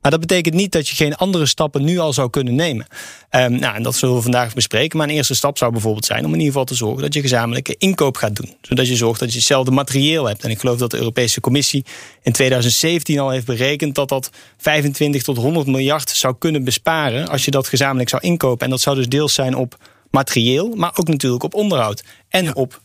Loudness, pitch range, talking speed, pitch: -17 LUFS, 125-150 Hz, 240 wpm, 135 Hz